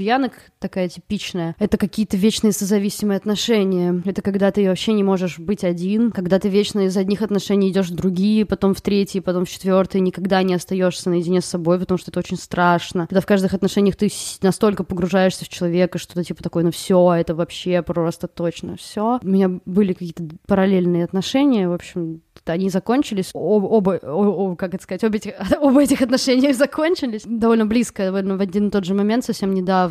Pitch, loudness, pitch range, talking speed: 195 Hz, -19 LUFS, 180-210 Hz, 190 wpm